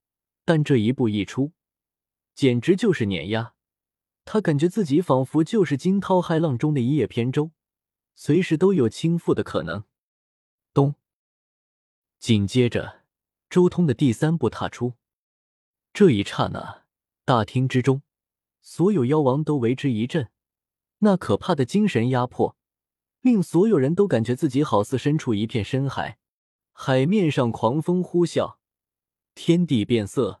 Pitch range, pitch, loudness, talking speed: 115-170 Hz, 135 Hz, -22 LUFS, 205 characters per minute